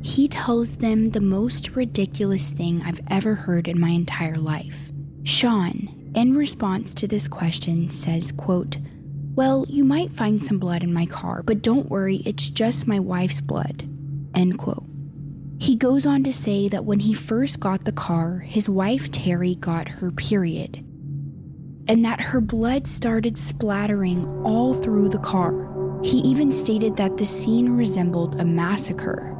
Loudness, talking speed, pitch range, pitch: -22 LUFS, 160 wpm, 145-215 Hz, 180 Hz